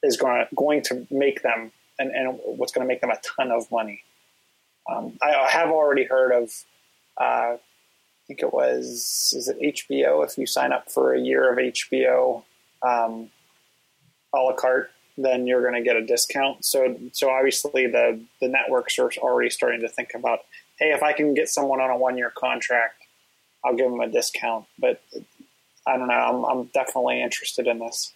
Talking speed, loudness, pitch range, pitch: 190 wpm, -23 LUFS, 115-150 Hz, 130 Hz